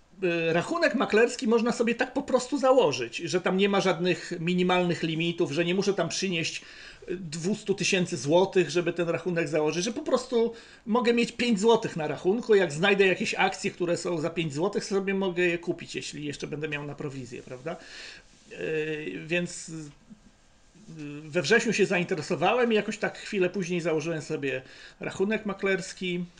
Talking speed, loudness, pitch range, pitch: 160 wpm, -27 LUFS, 165-205 Hz, 180 Hz